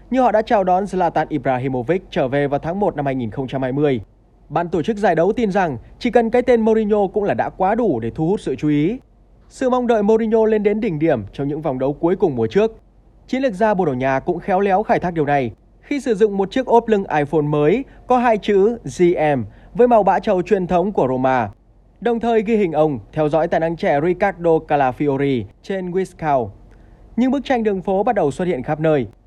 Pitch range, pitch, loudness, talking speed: 145-220 Hz, 180 Hz, -18 LUFS, 230 wpm